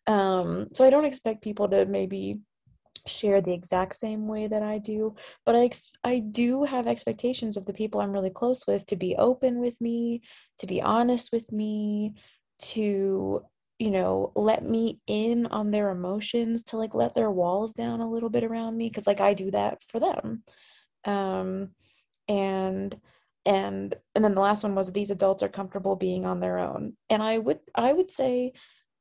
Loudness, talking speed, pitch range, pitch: -27 LUFS, 185 wpm, 195-230 Hz, 210 Hz